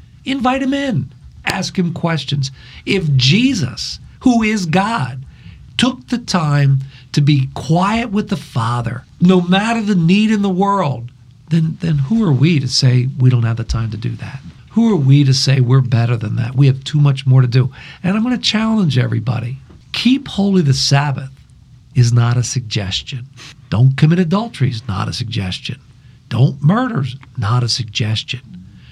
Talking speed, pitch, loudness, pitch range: 175 wpm, 135 Hz, -16 LUFS, 125-185 Hz